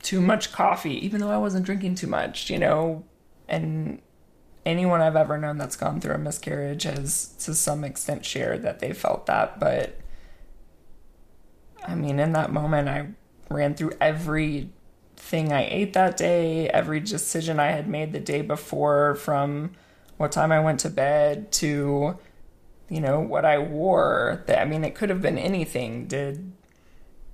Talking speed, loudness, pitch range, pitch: 165 wpm, -25 LUFS, 145-170 Hz, 155 Hz